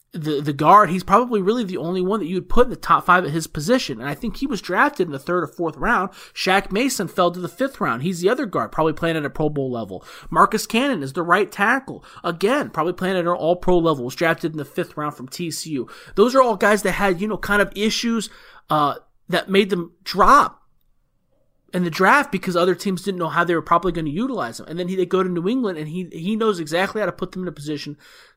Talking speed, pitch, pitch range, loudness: 260 wpm, 180 Hz, 165-205 Hz, -20 LUFS